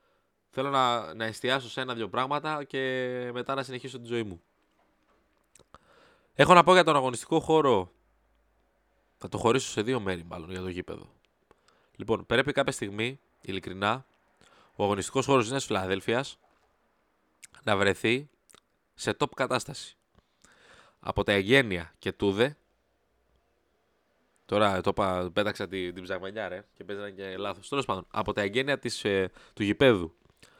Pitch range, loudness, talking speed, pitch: 95-130 Hz, -28 LUFS, 140 wpm, 110 Hz